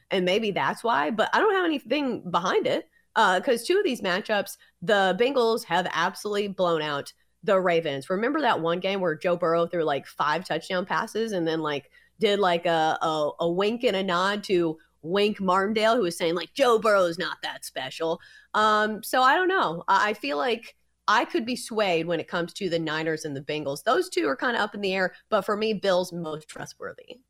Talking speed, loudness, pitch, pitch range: 215 wpm, -25 LUFS, 190 Hz, 170-220 Hz